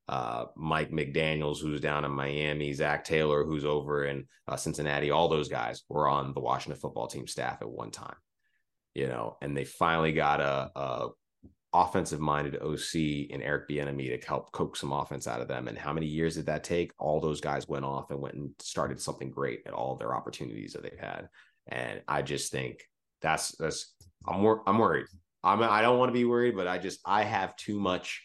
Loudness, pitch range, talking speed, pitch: -31 LUFS, 70-80 Hz, 210 wpm, 75 Hz